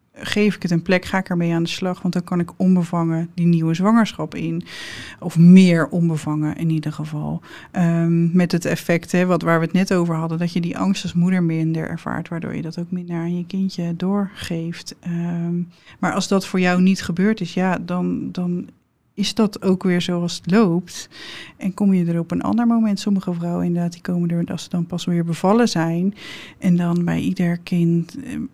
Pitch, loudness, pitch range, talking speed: 175 Hz, -20 LUFS, 170-185 Hz, 200 wpm